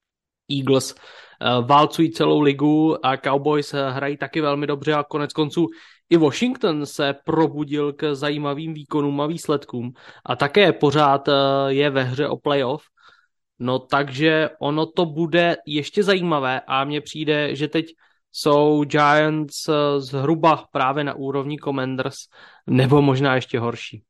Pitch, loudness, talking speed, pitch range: 145 Hz, -20 LUFS, 130 wpm, 140-155 Hz